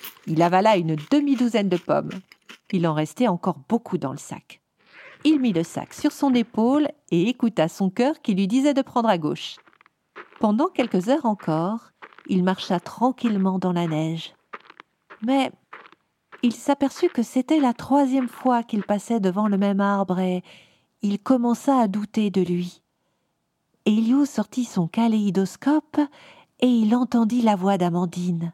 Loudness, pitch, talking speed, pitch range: -22 LUFS, 215 Hz, 155 wpm, 185-255 Hz